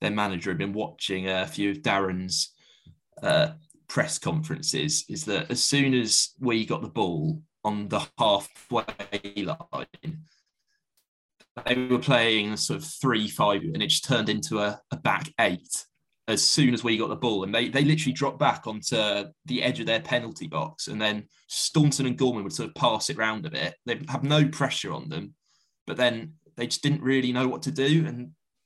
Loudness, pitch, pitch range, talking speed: -26 LUFS, 125 Hz, 105-150 Hz, 190 wpm